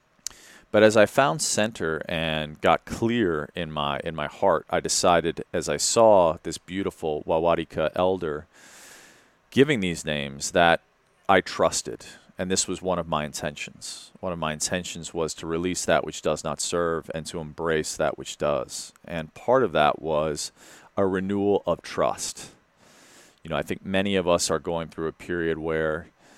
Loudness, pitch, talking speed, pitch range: -25 LUFS, 85 Hz, 170 wpm, 80-95 Hz